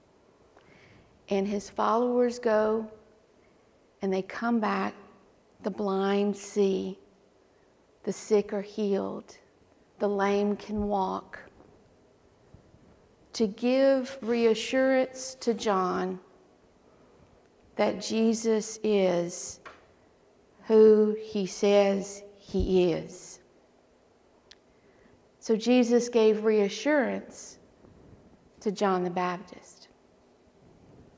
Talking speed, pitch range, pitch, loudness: 75 wpm, 195-225 Hz, 210 Hz, -27 LUFS